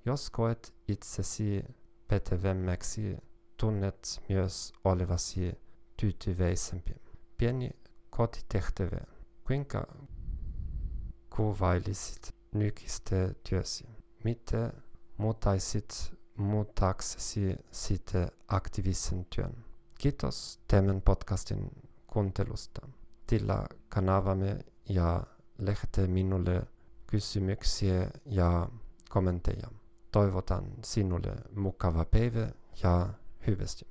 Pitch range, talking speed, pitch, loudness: 90-115 Hz, 65 wpm, 100 Hz, -33 LUFS